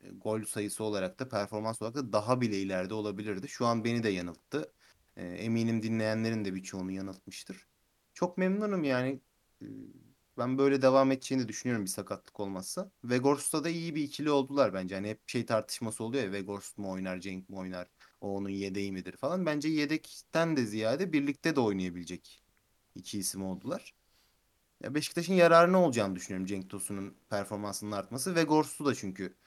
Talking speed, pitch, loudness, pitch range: 165 wpm, 110 Hz, -32 LUFS, 95-135 Hz